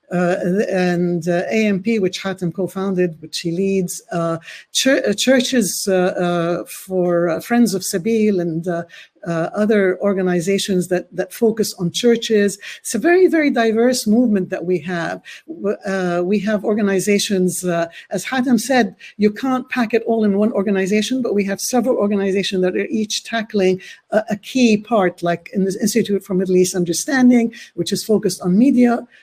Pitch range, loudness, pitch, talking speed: 180-225 Hz, -18 LUFS, 195 Hz, 170 wpm